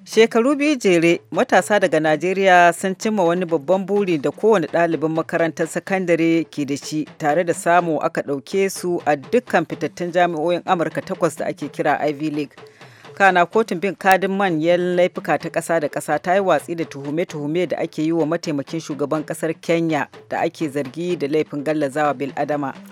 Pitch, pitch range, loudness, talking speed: 165 Hz, 155-185 Hz, -19 LUFS, 170 wpm